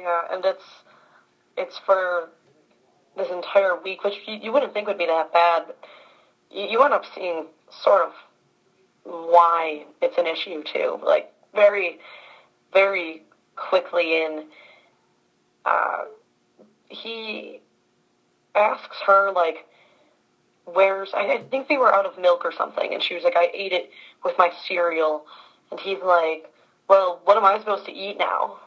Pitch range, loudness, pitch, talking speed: 165-195 Hz, -22 LUFS, 180 Hz, 150 wpm